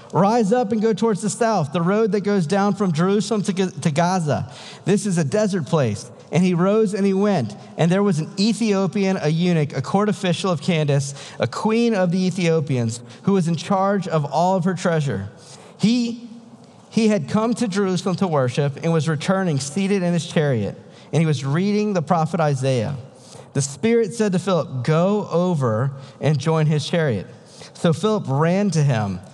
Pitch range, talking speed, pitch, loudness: 150-200 Hz, 190 wpm, 180 Hz, -20 LUFS